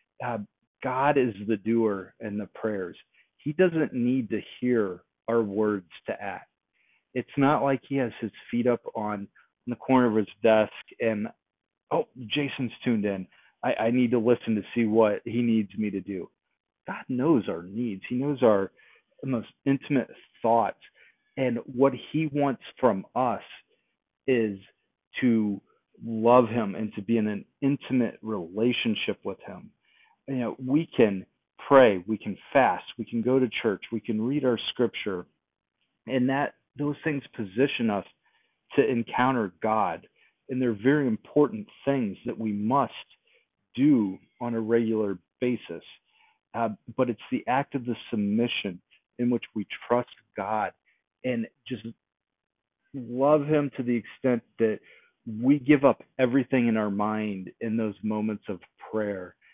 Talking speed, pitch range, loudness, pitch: 155 wpm, 110-135 Hz, -27 LUFS, 120 Hz